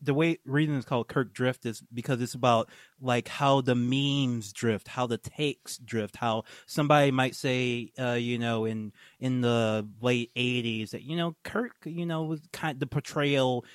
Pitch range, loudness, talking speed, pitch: 120-145 Hz, -29 LUFS, 190 wpm, 125 Hz